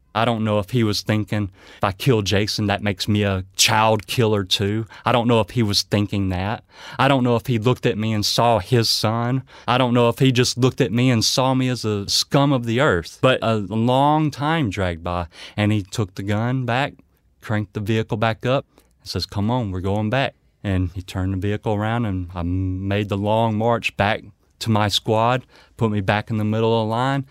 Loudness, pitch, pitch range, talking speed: -20 LUFS, 110 Hz, 100-120 Hz, 230 wpm